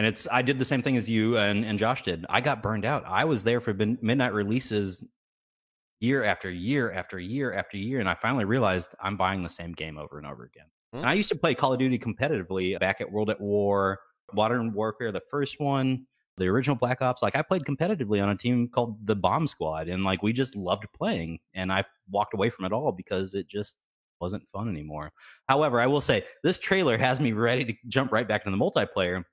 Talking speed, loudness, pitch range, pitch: 230 wpm, -27 LUFS, 95-130 Hz, 110 Hz